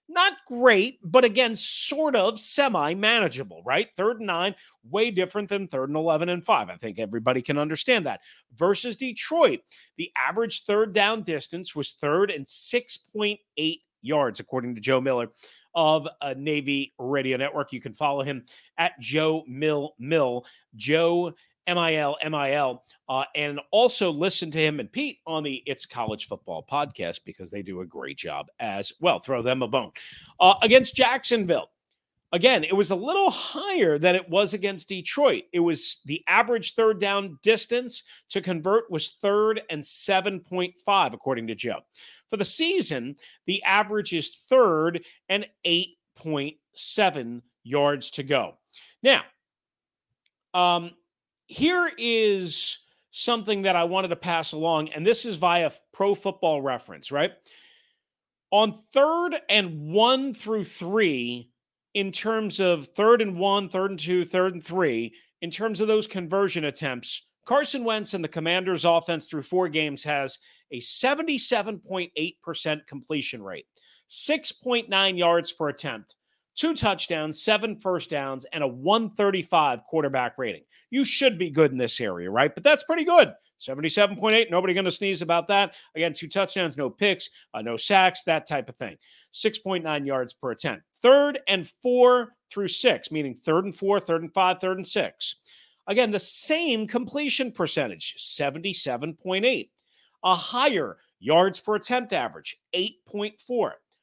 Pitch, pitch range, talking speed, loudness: 185 Hz, 155-220 Hz, 150 wpm, -24 LUFS